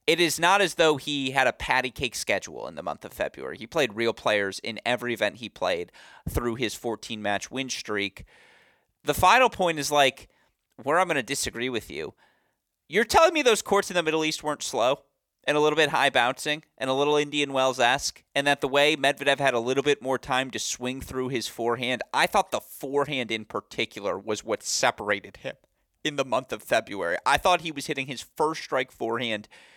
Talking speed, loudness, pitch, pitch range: 215 wpm, -25 LUFS, 140 Hz, 125-150 Hz